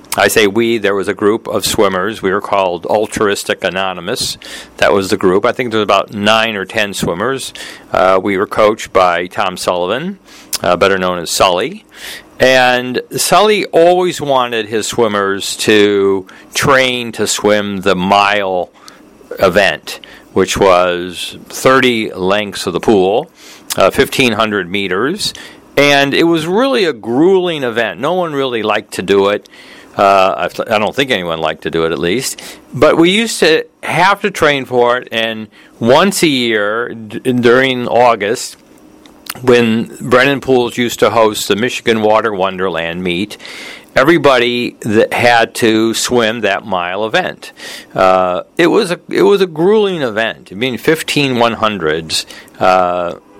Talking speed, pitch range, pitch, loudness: 155 wpm, 100-130 Hz, 115 Hz, -12 LUFS